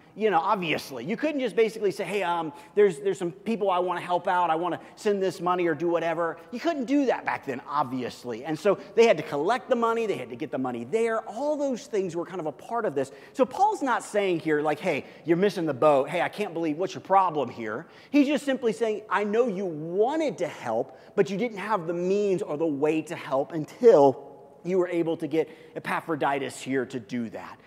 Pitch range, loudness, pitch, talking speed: 160-220 Hz, -26 LUFS, 180 Hz, 240 wpm